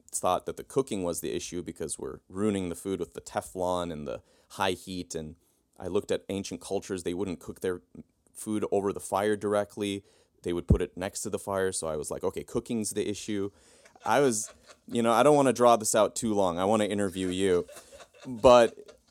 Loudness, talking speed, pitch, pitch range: -29 LUFS, 215 wpm, 100 Hz, 90-110 Hz